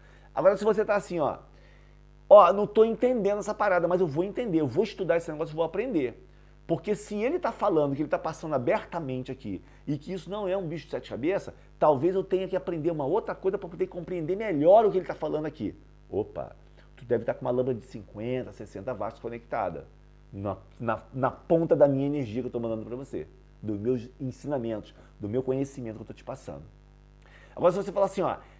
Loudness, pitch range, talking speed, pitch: -27 LUFS, 125-185 Hz, 220 wpm, 160 Hz